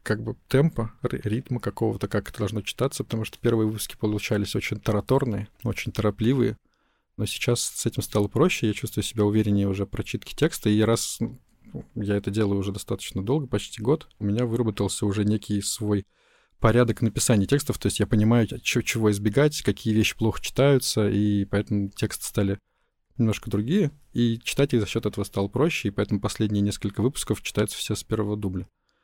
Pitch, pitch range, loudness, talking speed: 110 Hz, 100-120 Hz, -25 LUFS, 175 wpm